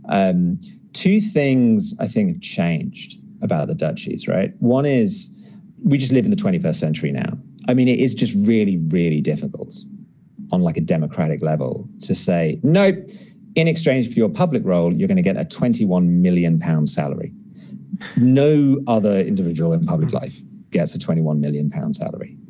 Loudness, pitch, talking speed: -19 LUFS, 140 Hz, 175 wpm